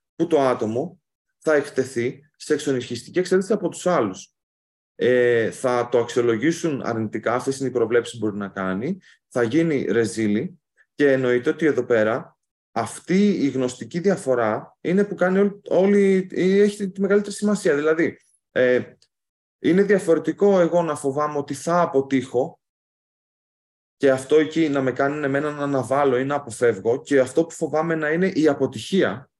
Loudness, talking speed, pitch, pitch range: -21 LUFS, 155 wpm, 145 Hz, 125-170 Hz